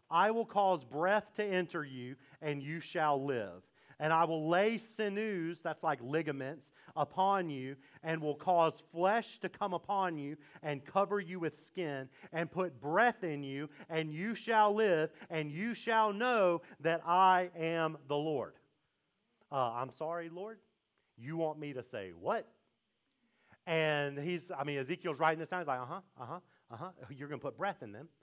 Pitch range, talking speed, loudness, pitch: 145-190 Hz, 180 wpm, -35 LUFS, 165 Hz